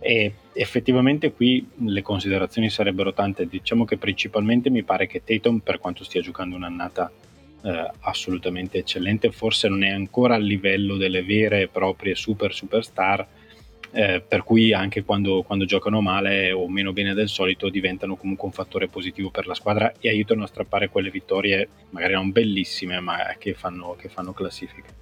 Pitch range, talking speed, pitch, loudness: 95-110 Hz, 170 wpm, 100 Hz, -23 LUFS